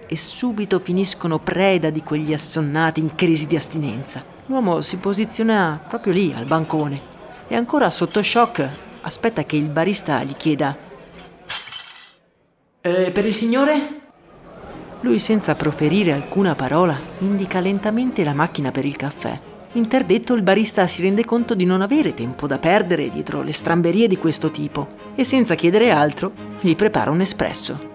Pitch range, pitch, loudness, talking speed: 155-210 Hz, 180 Hz, -19 LUFS, 150 wpm